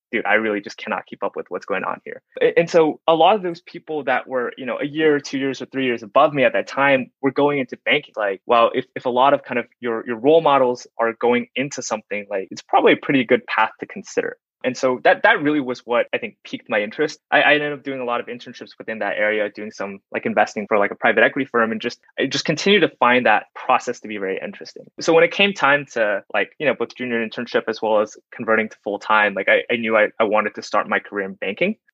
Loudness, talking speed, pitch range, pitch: -19 LUFS, 270 wpm, 115-155 Hz, 130 Hz